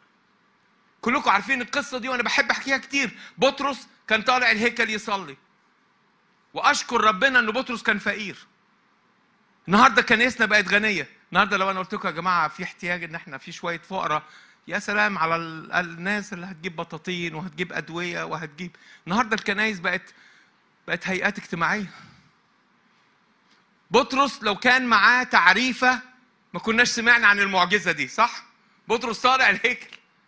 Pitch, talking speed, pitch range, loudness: 210 Hz, 135 wpm, 180-245 Hz, -22 LUFS